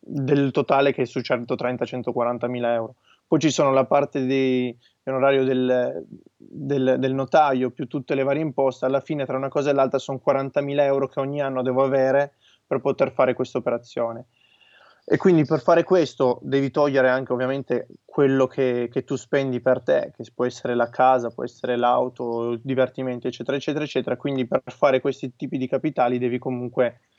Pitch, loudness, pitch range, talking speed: 130 Hz, -23 LUFS, 125-140 Hz, 185 wpm